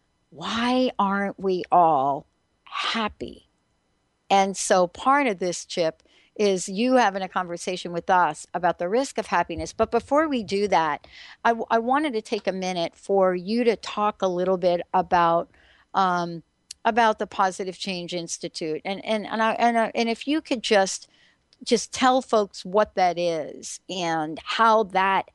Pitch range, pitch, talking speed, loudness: 180-230 Hz, 195 Hz, 165 wpm, -24 LUFS